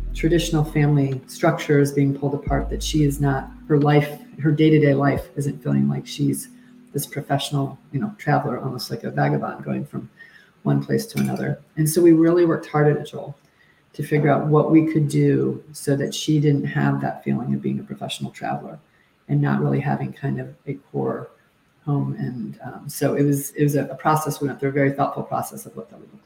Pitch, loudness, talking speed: 140 Hz, -21 LUFS, 210 wpm